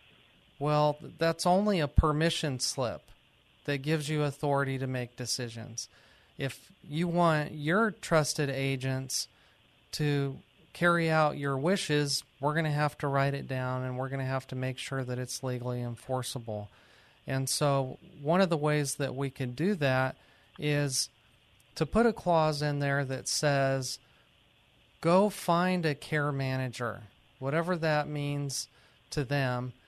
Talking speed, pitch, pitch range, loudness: 150 wpm, 140 Hz, 130-155 Hz, -30 LUFS